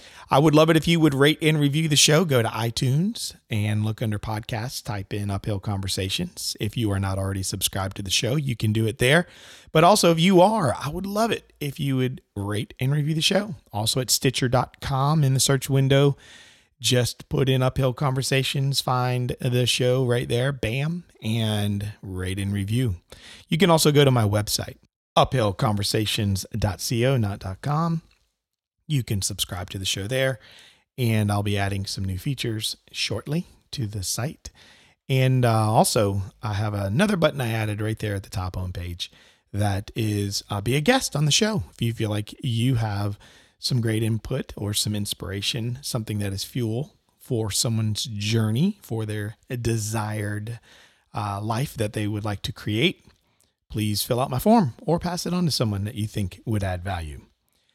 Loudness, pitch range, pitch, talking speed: -24 LUFS, 105-135 Hz, 115 Hz, 185 wpm